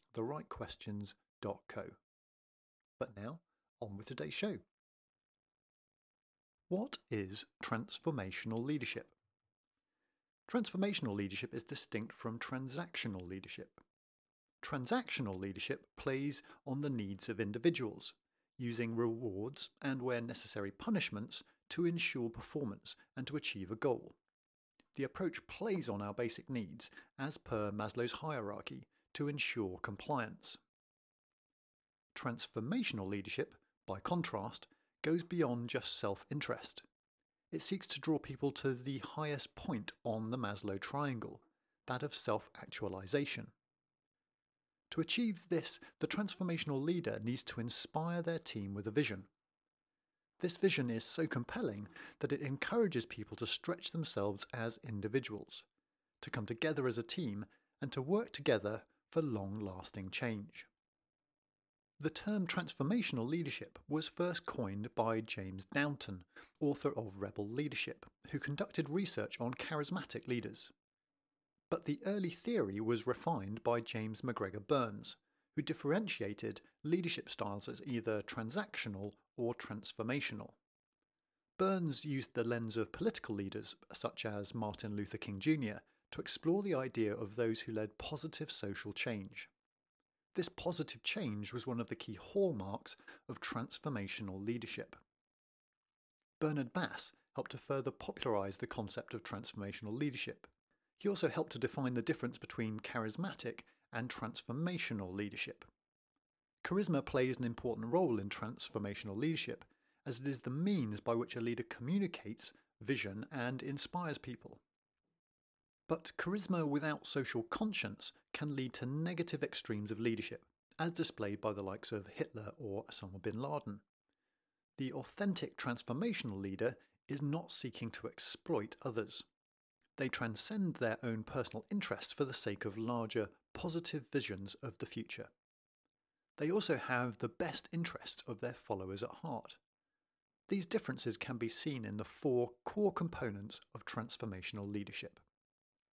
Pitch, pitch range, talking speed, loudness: 125 Hz, 110-155 Hz, 130 wpm, -40 LUFS